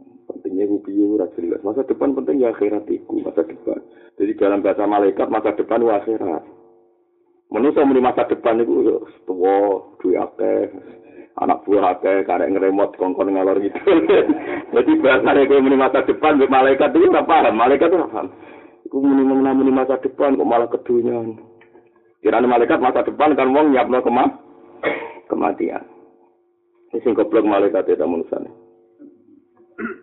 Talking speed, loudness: 140 wpm, -17 LUFS